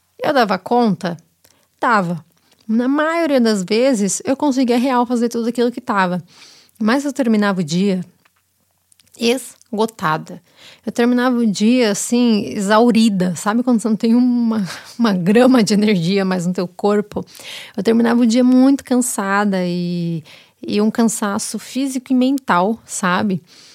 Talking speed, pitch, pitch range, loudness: 140 wpm, 220 Hz, 195-245 Hz, -17 LUFS